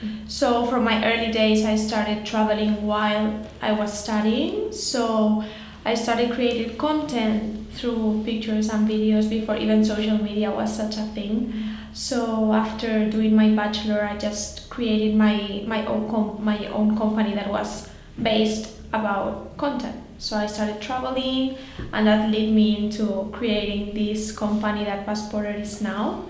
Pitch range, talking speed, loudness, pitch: 210-225 Hz, 150 wpm, -23 LUFS, 215 Hz